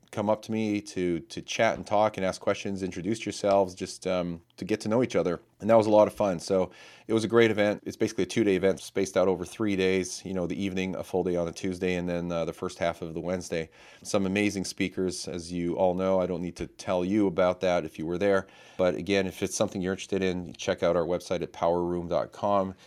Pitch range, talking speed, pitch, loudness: 90-100 Hz, 255 wpm, 95 Hz, -28 LUFS